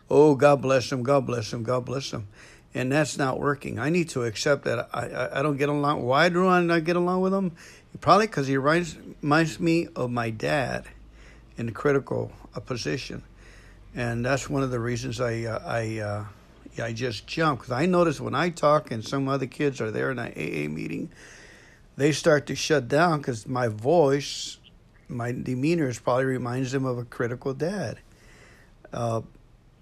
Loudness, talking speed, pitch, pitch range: -25 LUFS, 190 wpm, 135 Hz, 120-150 Hz